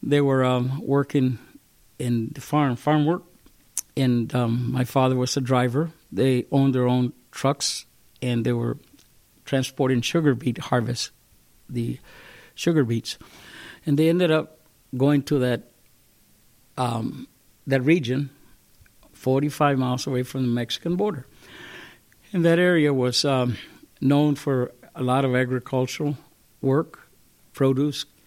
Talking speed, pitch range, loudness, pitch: 130 wpm, 125-145 Hz, -23 LUFS, 135 Hz